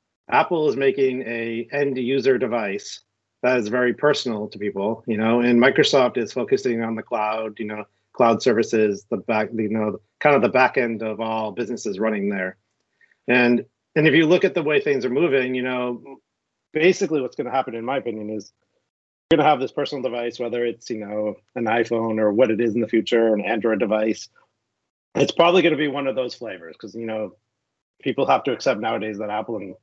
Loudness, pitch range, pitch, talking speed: -21 LUFS, 110-130 Hz, 115 Hz, 210 wpm